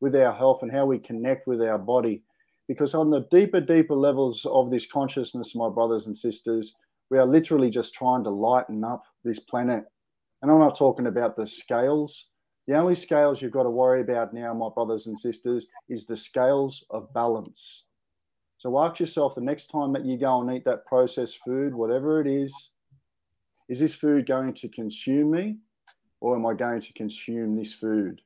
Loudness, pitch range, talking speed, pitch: -25 LUFS, 115-140 Hz, 190 wpm, 125 Hz